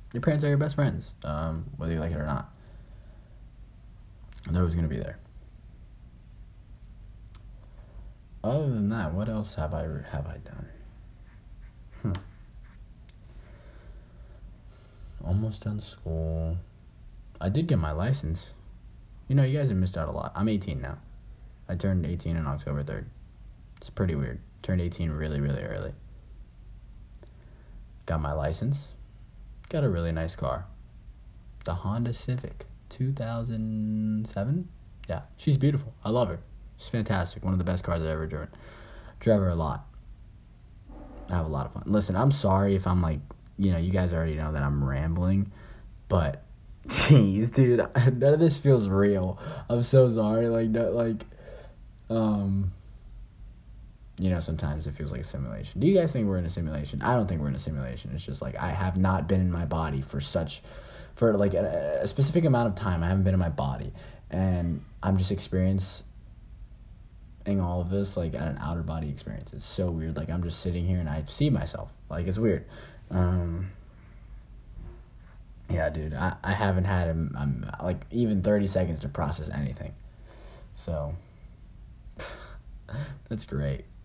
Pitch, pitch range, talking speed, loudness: 95 Hz, 80-110 Hz, 165 wpm, -28 LUFS